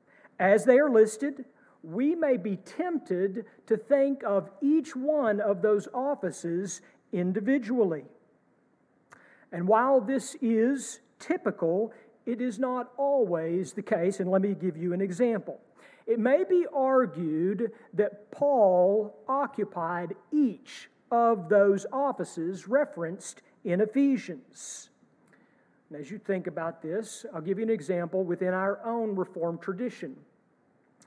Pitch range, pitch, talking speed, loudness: 185-260 Hz, 215 Hz, 125 wpm, -28 LUFS